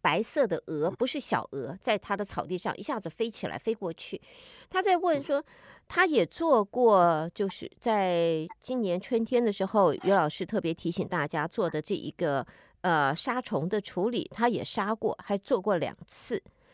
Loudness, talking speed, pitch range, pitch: -29 LUFS, 250 characters per minute, 175-245 Hz, 205 Hz